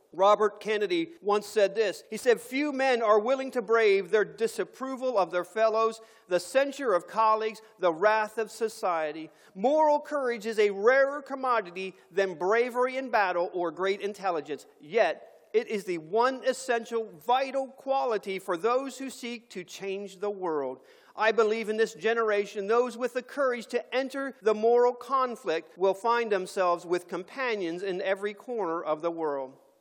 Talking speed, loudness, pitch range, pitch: 160 wpm, -28 LUFS, 195-250 Hz, 220 Hz